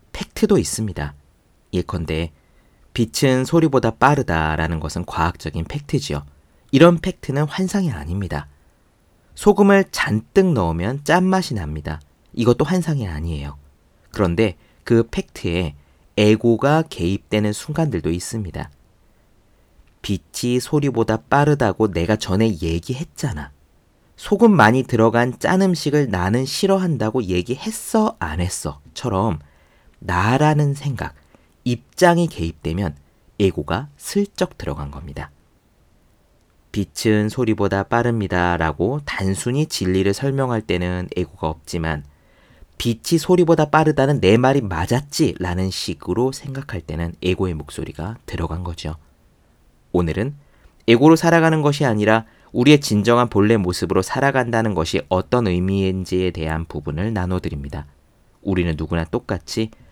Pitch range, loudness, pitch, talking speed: 85-130 Hz, -19 LUFS, 100 Hz, 285 characters per minute